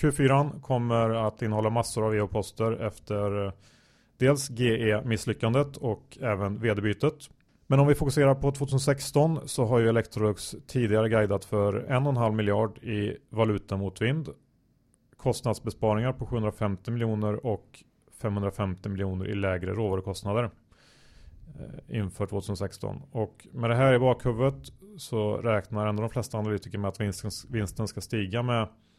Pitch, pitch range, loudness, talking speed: 110 Hz, 105-125 Hz, -28 LUFS, 135 wpm